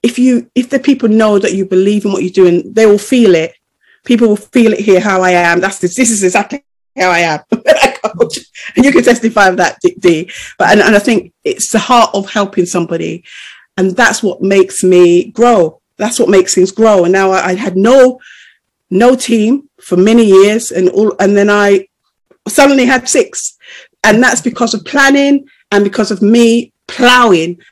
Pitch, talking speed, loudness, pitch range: 215 Hz, 195 wpm, -9 LUFS, 190-245 Hz